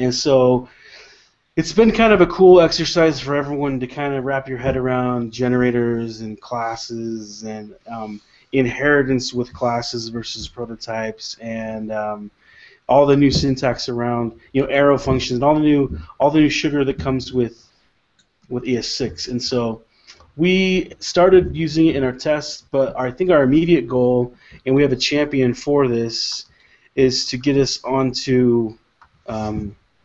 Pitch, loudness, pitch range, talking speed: 125 Hz, -18 LUFS, 115-145 Hz, 160 wpm